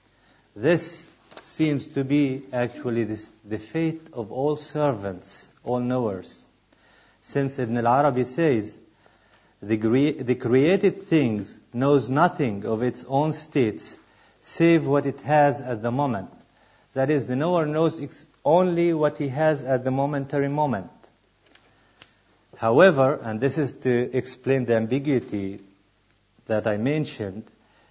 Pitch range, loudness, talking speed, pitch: 115-150 Hz, -24 LUFS, 125 wpm, 130 Hz